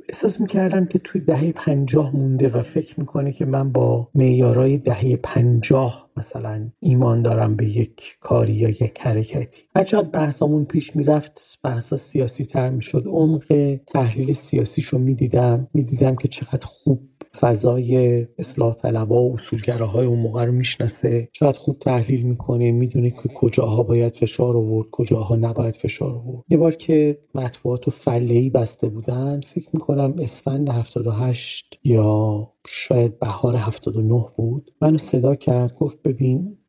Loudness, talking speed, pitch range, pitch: -20 LUFS, 140 wpm, 120-145 Hz, 130 Hz